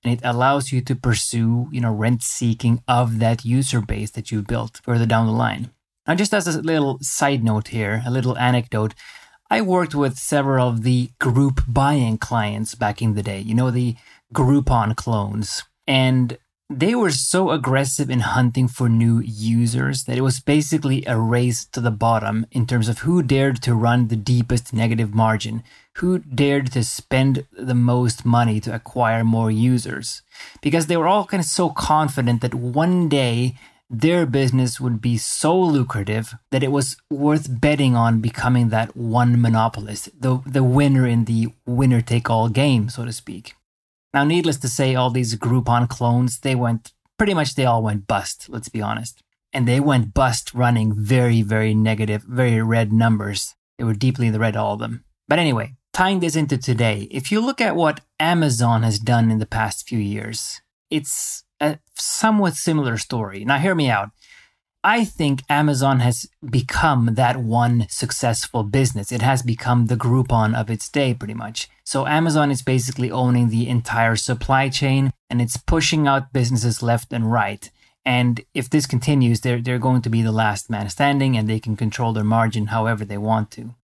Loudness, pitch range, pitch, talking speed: -20 LUFS, 115-135 Hz, 120 Hz, 185 wpm